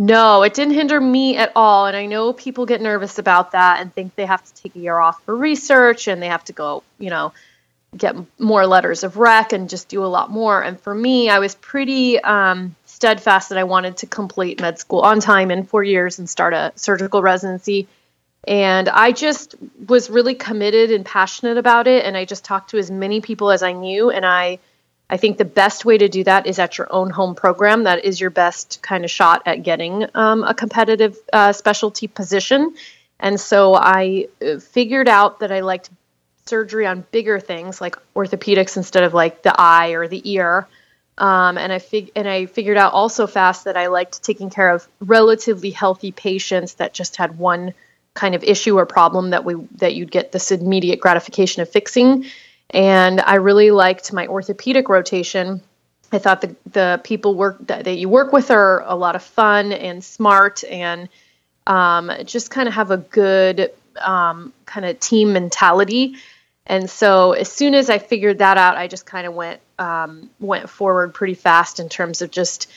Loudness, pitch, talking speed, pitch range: -16 LUFS, 195 Hz, 200 wpm, 185-220 Hz